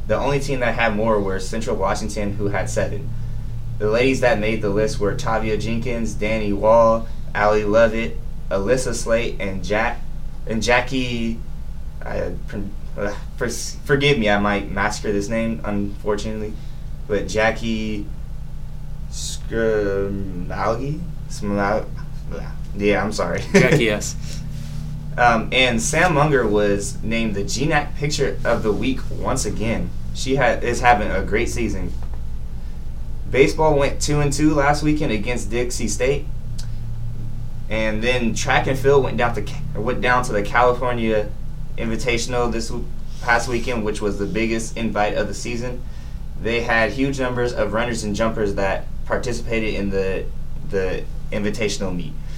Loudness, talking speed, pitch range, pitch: -21 LUFS, 140 wpm, 105-135 Hz, 115 Hz